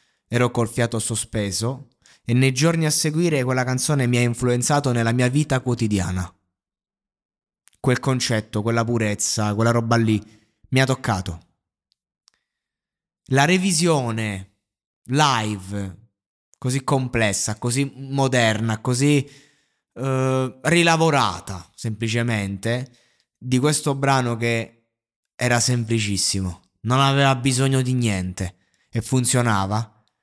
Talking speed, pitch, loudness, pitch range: 105 wpm, 120 Hz, -21 LUFS, 105-130 Hz